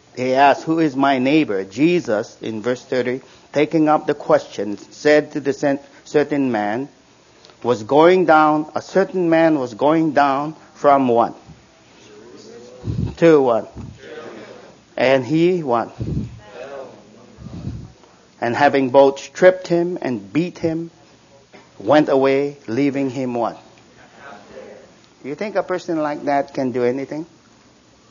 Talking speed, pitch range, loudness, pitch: 120 wpm, 130-160 Hz, -18 LUFS, 140 Hz